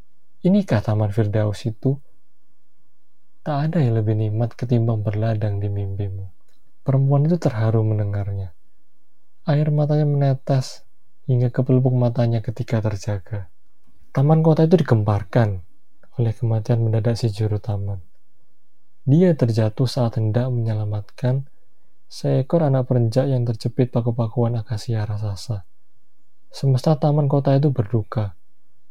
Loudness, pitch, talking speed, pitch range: -21 LUFS, 120 Hz, 110 wpm, 105-135 Hz